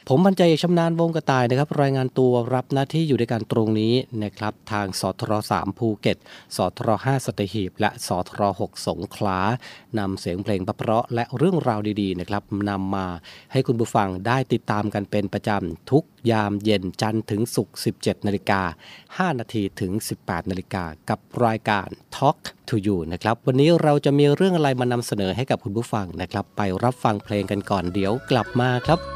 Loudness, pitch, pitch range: -23 LUFS, 110 Hz, 100-130 Hz